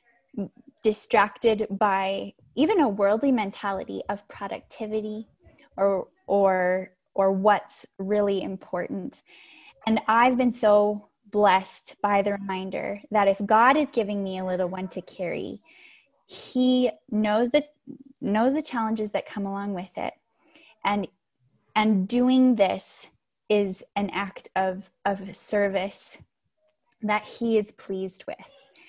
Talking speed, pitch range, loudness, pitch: 125 wpm, 195-235 Hz, -25 LUFS, 210 Hz